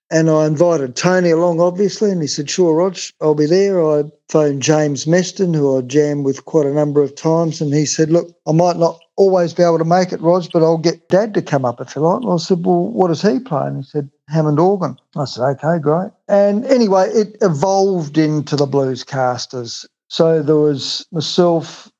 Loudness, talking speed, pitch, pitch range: -16 LUFS, 220 wpm, 165 Hz, 150-180 Hz